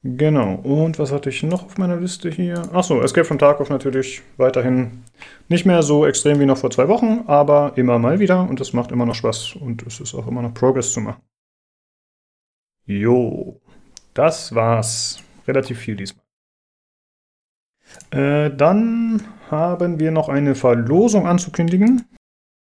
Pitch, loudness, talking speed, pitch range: 145 Hz, -18 LUFS, 155 wpm, 125-175 Hz